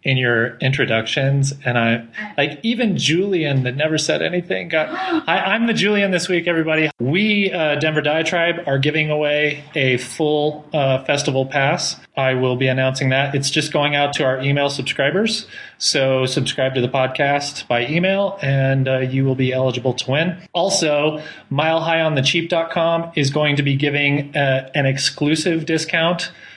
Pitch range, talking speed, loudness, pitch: 135-165 Hz, 170 wpm, -18 LUFS, 145 Hz